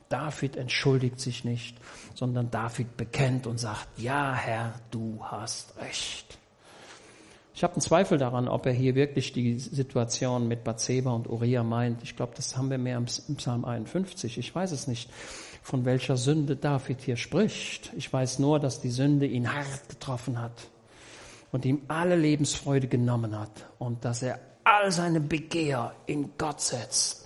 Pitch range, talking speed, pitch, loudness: 120-145 Hz, 165 wpm, 130 Hz, -29 LUFS